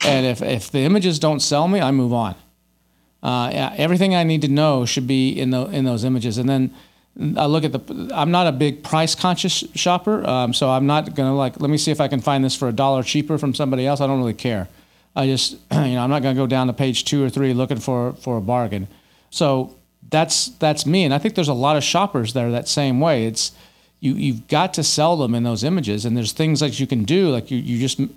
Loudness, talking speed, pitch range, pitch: -19 LUFS, 260 wpm, 125-155 Hz, 135 Hz